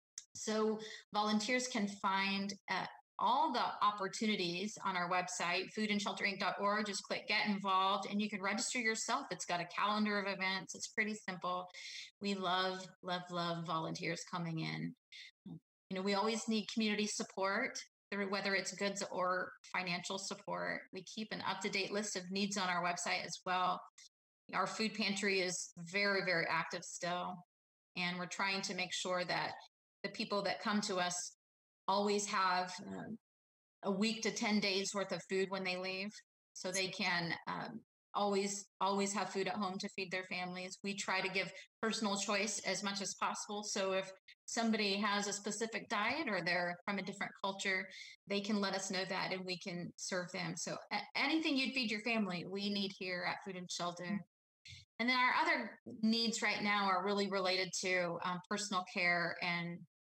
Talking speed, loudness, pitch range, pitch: 175 wpm, -38 LUFS, 185-210 Hz, 195 Hz